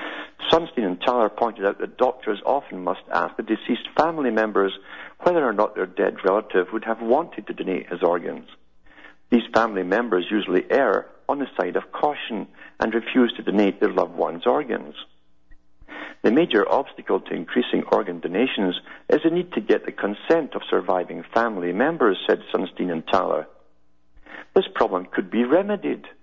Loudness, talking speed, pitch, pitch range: -23 LUFS, 165 wpm, 110 Hz, 90-115 Hz